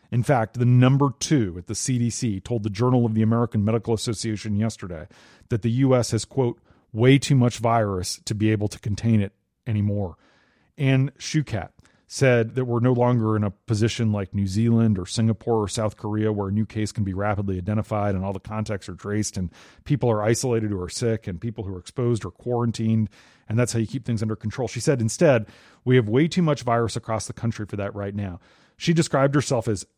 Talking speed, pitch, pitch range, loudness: 215 wpm, 110 Hz, 105-120 Hz, -23 LUFS